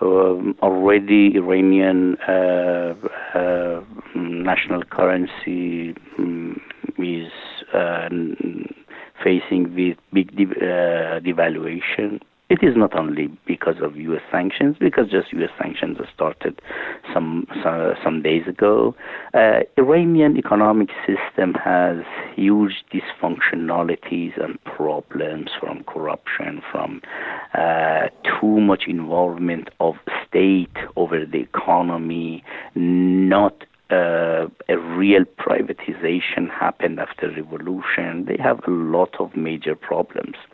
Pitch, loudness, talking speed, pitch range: 90 Hz, -20 LUFS, 105 wpm, 85-95 Hz